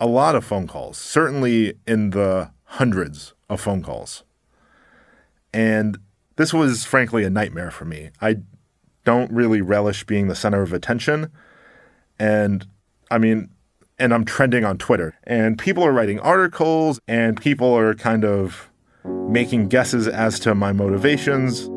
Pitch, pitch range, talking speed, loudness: 110 Hz, 100-125 Hz, 145 wpm, -20 LUFS